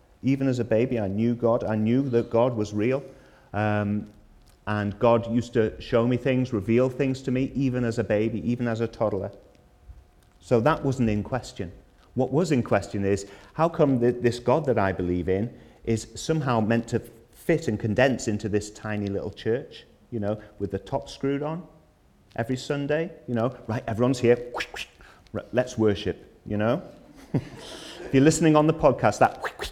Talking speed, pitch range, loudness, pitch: 180 wpm, 105-130 Hz, -25 LUFS, 115 Hz